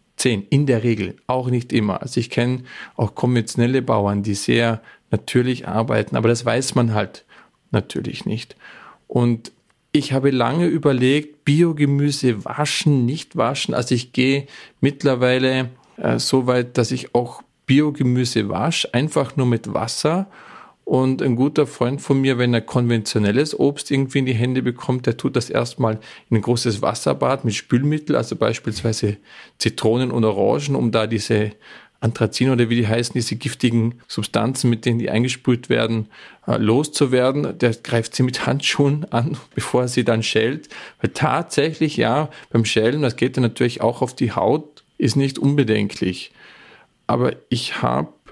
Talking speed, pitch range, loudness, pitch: 155 wpm, 115-140 Hz, -20 LUFS, 125 Hz